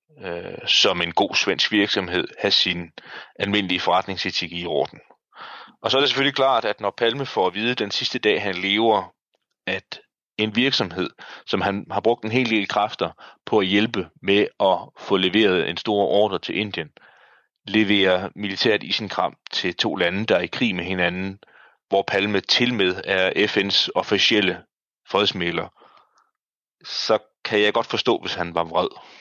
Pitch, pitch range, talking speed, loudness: 105 Hz, 95-115 Hz, 160 wpm, -21 LUFS